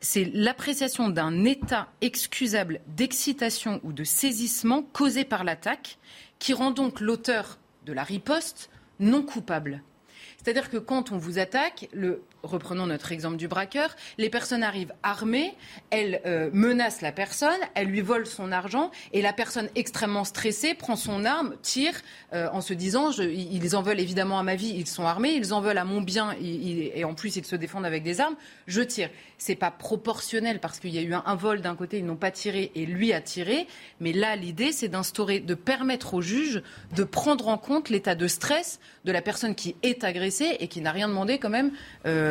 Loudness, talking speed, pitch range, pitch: -27 LUFS, 200 wpm, 180-245 Hz, 210 Hz